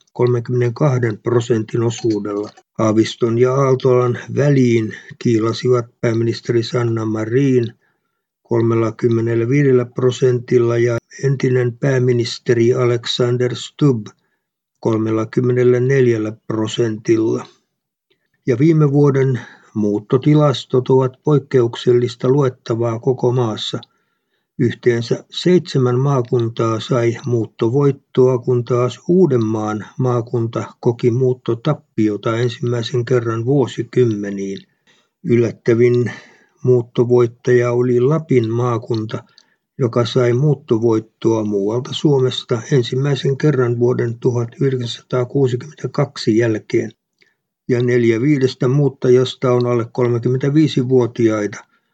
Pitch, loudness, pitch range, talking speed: 125 Hz, -17 LUFS, 115-130 Hz, 75 wpm